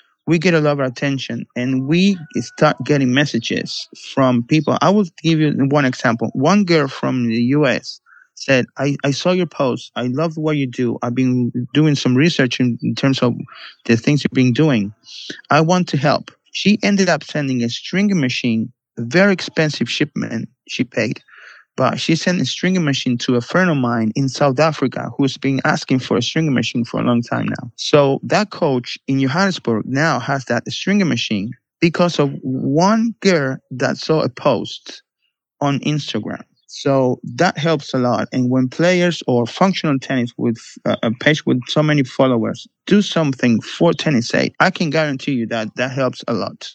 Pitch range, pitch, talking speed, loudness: 125-160 Hz, 140 Hz, 185 wpm, -17 LUFS